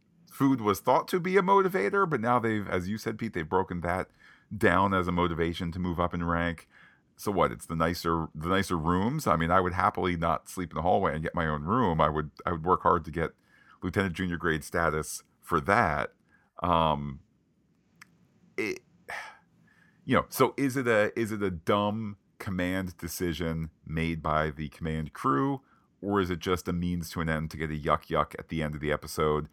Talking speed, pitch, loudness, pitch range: 205 wpm, 90 Hz, -29 LUFS, 80-100 Hz